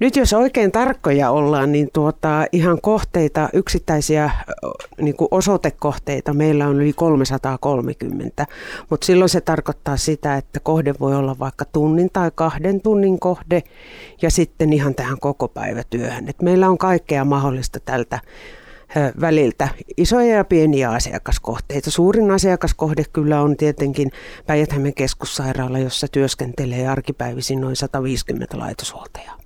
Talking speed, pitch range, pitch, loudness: 125 wpm, 140-170 Hz, 150 Hz, -18 LUFS